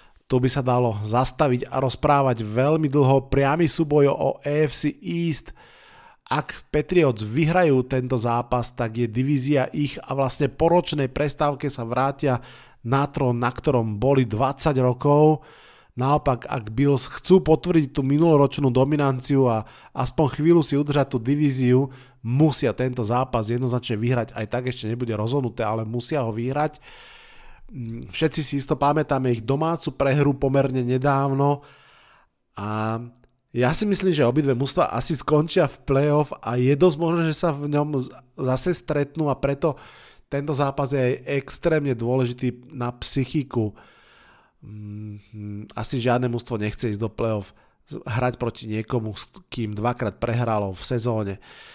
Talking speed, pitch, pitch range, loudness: 140 wpm, 135 Hz, 120-150 Hz, -23 LUFS